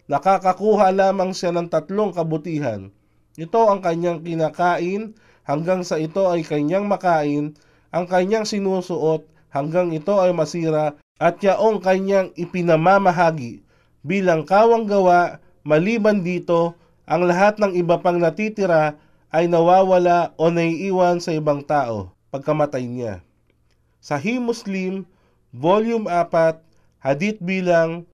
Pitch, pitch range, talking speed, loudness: 170 Hz, 155-190 Hz, 115 wpm, -19 LUFS